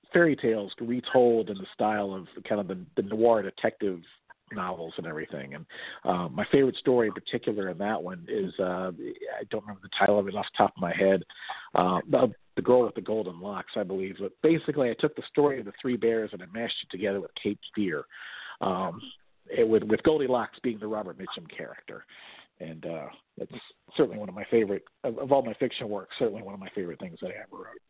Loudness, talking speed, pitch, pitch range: -28 LUFS, 220 wpm, 110 Hz, 100-125 Hz